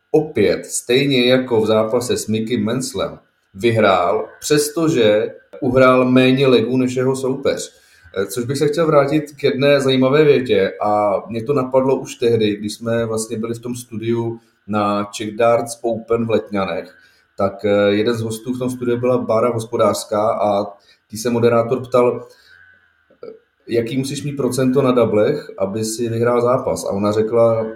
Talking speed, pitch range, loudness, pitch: 155 wpm, 110-135 Hz, -17 LUFS, 120 Hz